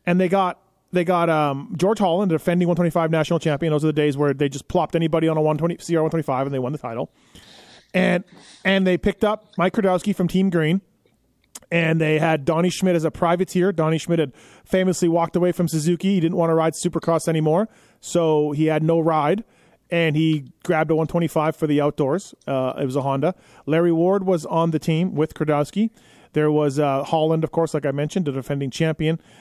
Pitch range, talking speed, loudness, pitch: 155-180 Hz, 210 wpm, -21 LUFS, 165 Hz